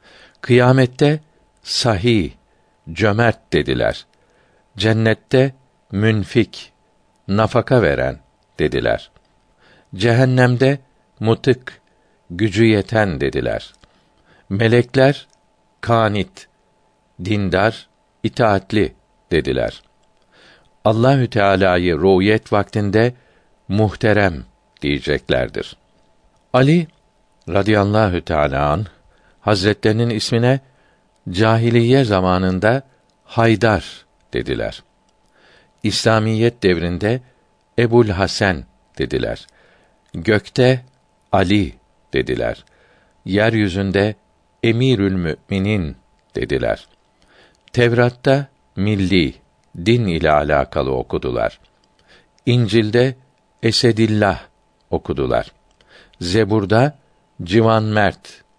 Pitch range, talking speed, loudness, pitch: 100-120 Hz, 60 wpm, -17 LUFS, 110 Hz